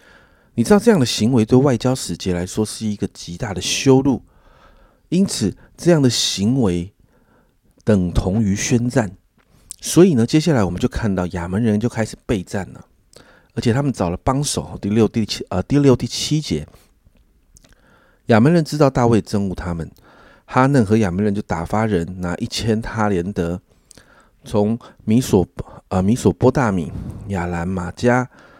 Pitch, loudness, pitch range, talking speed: 110 Hz, -18 LUFS, 95-125 Hz, 235 characters per minute